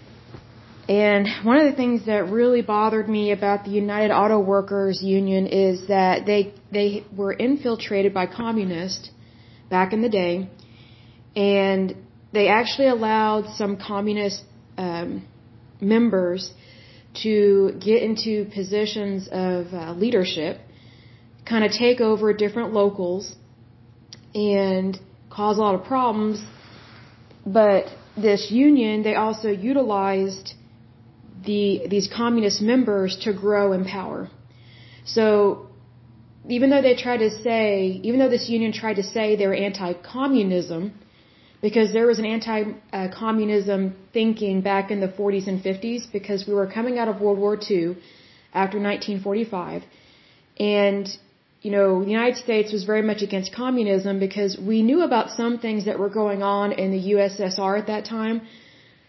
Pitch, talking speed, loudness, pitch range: 200 Hz, 135 wpm, -22 LUFS, 185-215 Hz